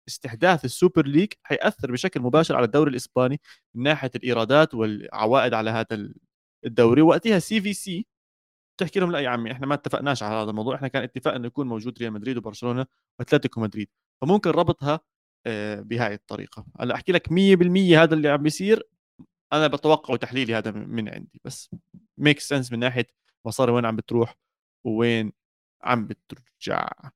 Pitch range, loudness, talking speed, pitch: 115-160 Hz, -23 LUFS, 160 wpm, 130 Hz